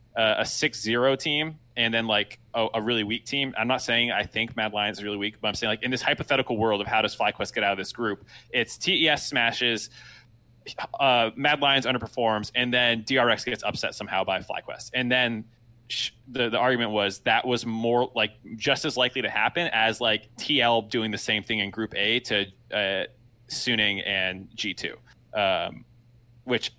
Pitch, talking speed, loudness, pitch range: 115 Hz, 195 wpm, -25 LUFS, 110-125 Hz